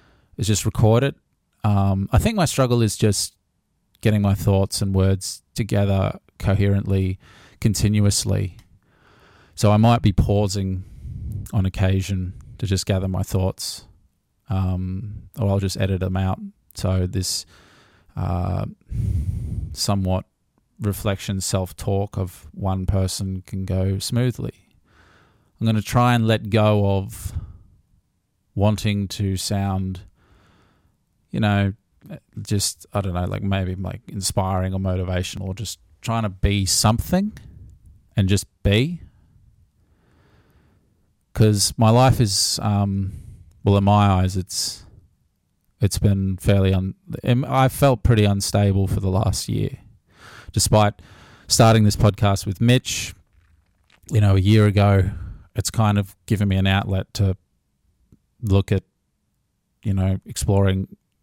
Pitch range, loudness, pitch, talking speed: 95-105 Hz, -21 LUFS, 100 Hz, 125 wpm